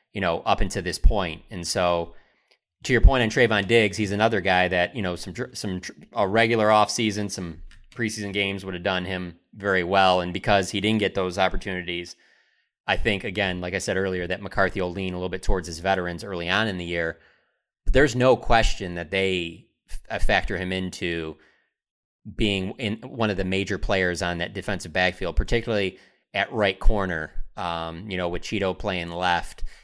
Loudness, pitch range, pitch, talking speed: -24 LUFS, 90-105 Hz, 95 Hz, 190 wpm